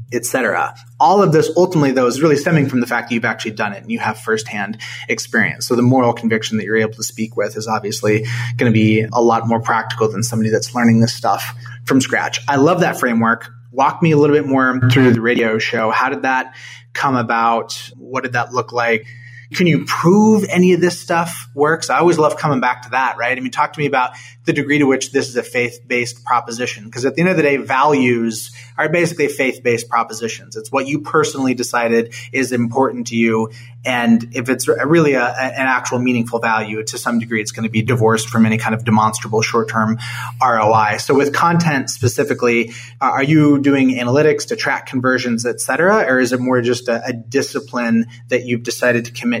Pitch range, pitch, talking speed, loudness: 115-135 Hz, 120 Hz, 215 wpm, -16 LUFS